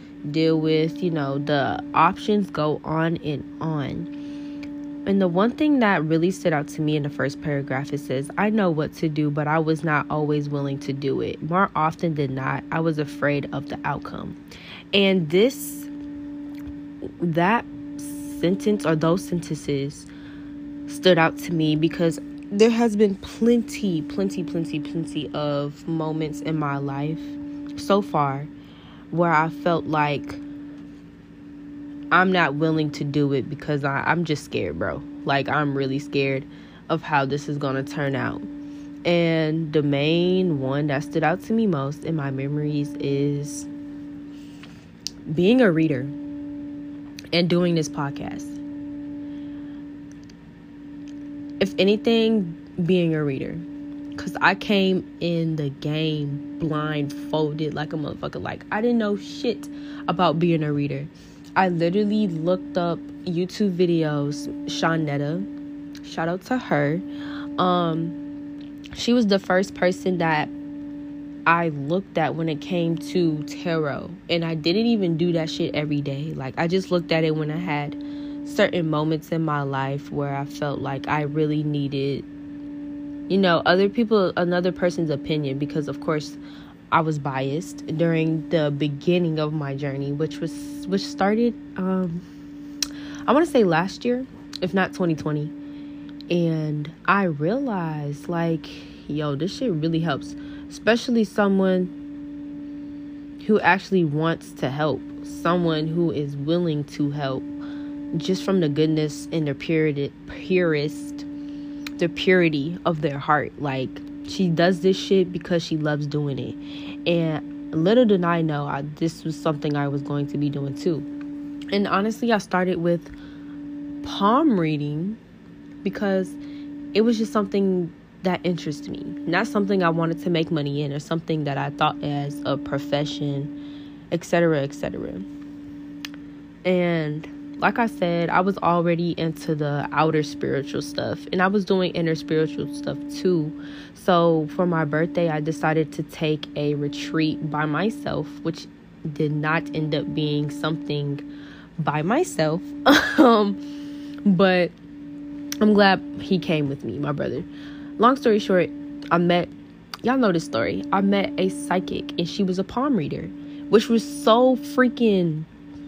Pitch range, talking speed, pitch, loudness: 145-210 Hz, 145 wpm, 165 Hz, -23 LUFS